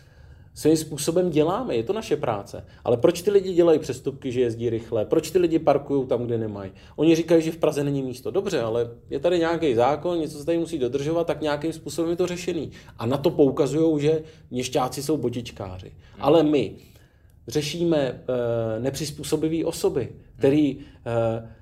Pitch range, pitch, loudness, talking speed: 120-160 Hz, 145 Hz, -24 LUFS, 170 wpm